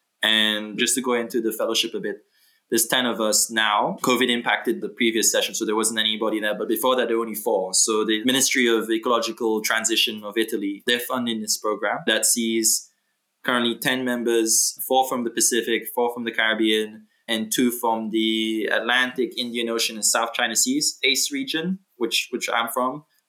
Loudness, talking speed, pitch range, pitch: -21 LUFS, 190 wpm, 110-125 Hz, 115 Hz